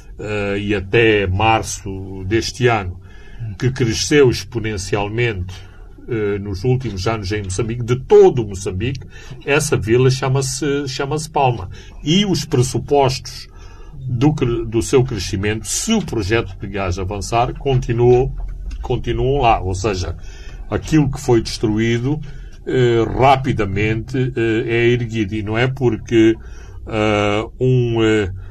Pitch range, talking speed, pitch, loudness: 100-125 Hz, 120 wpm, 115 Hz, -18 LUFS